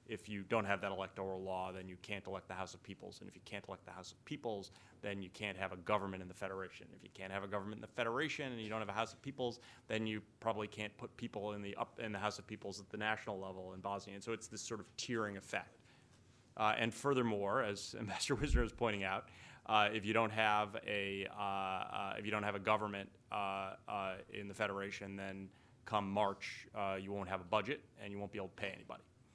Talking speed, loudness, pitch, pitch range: 250 wpm, -41 LUFS, 105 Hz, 95-110 Hz